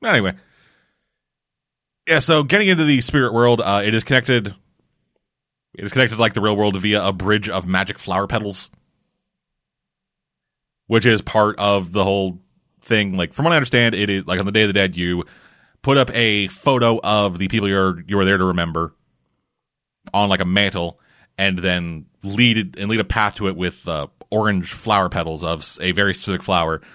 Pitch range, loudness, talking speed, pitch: 95-115 Hz, -18 LUFS, 190 wpm, 100 Hz